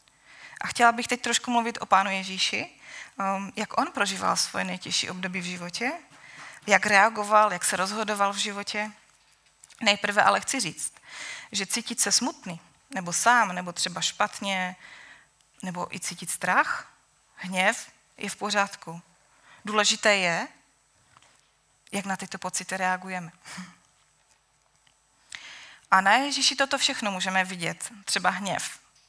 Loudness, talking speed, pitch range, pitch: -25 LUFS, 125 wpm, 185-215 Hz, 200 Hz